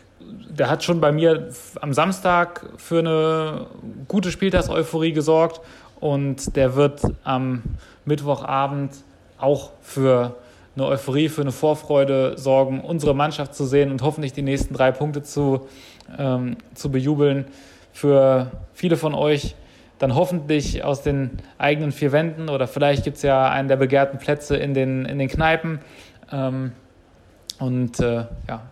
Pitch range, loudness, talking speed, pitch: 130-150 Hz, -21 LUFS, 140 wpm, 140 Hz